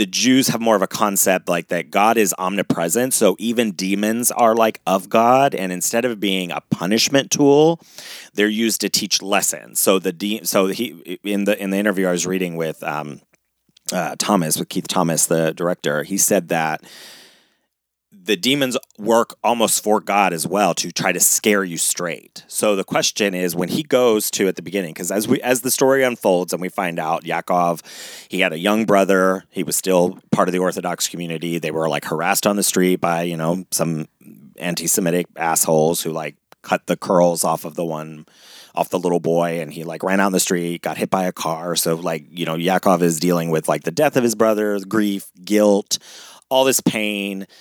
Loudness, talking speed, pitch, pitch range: -19 LUFS, 205 wpm, 95 Hz, 85-105 Hz